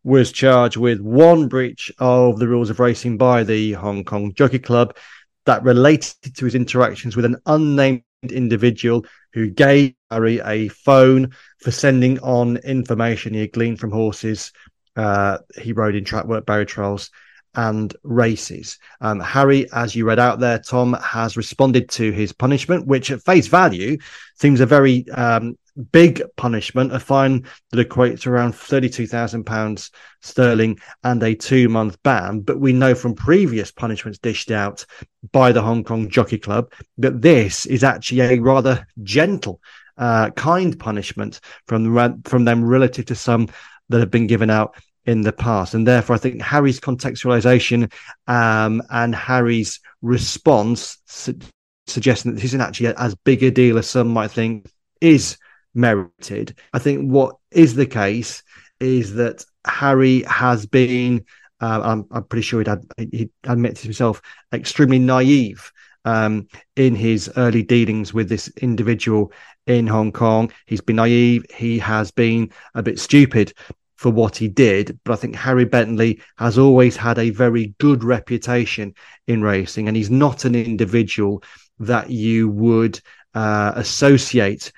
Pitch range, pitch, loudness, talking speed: 110-130 Hz, 120 Hz, -17 LUFS, 155 wpm